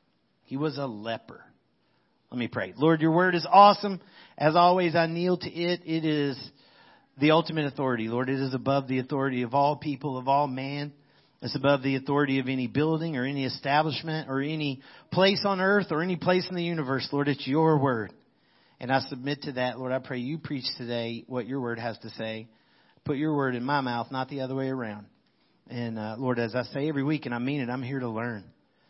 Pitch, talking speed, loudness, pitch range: 140 Hz, 215 wpm, -27 LUFS, 125-155 Hz